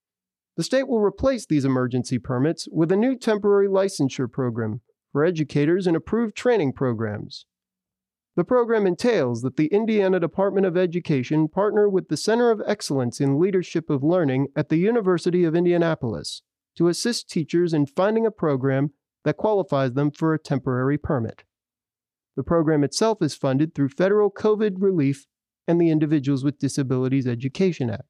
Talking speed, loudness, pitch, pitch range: 155 wpm, -22 LUFS, 155 Hz, 135-195 Hz